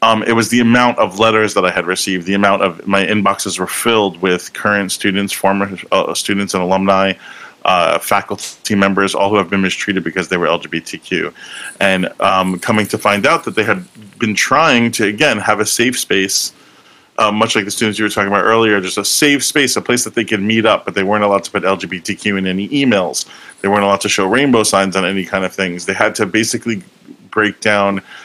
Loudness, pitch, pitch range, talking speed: -14 LUFS, 100 Hz, 95-110 Hz, 220 wpm